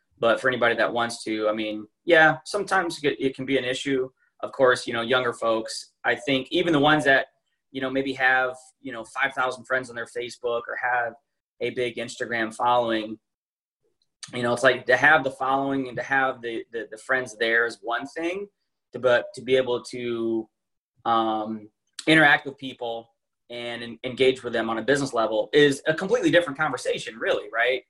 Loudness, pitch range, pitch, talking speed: -24 LUFS, 115-135 Hz, 125 Hz, 185 wpm